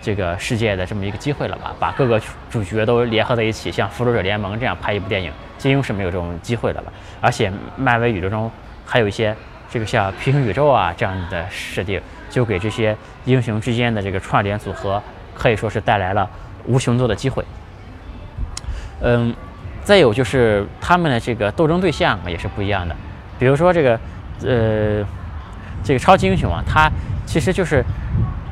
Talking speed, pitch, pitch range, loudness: 290 characters per minute, 110 Hz, 95-120 Hz, -19 LUFS